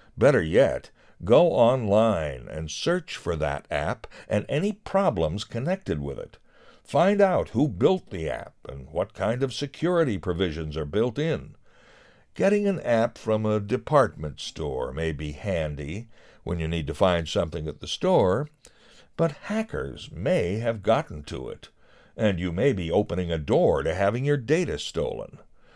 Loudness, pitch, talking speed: -25 LUFS, 110 Hz, 160 wpm